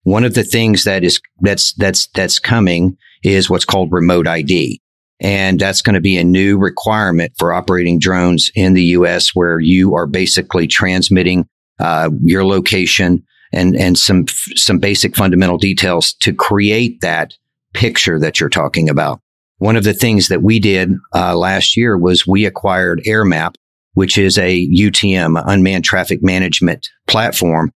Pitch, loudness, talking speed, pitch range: 95 Hz, -12 LUFS, 160 wpm, 90-100 Hz